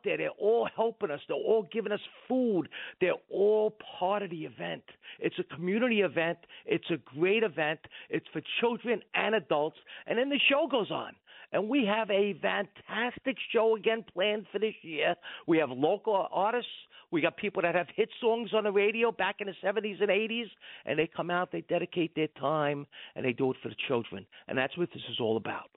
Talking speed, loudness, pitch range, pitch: 205 wpm, -31 LUFS, 165-225 Hz, 200 Hz